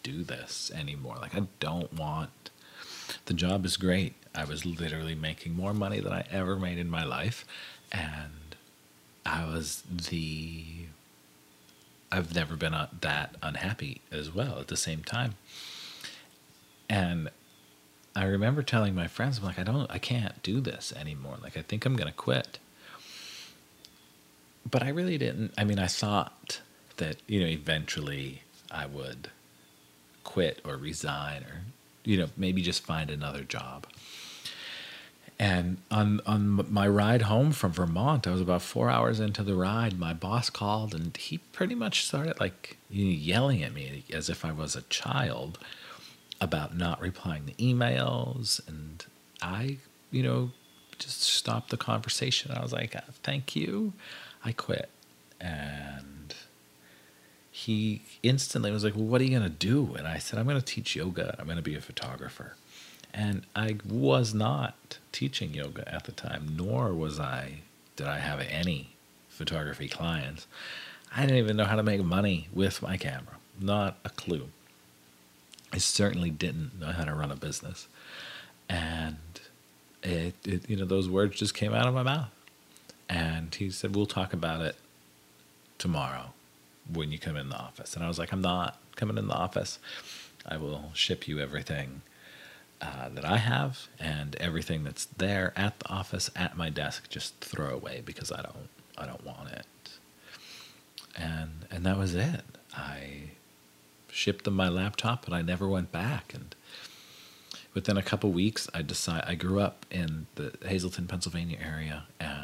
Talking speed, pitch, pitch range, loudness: 165 wpm, 85 Hz, 70-100 Hz, -31 LUFS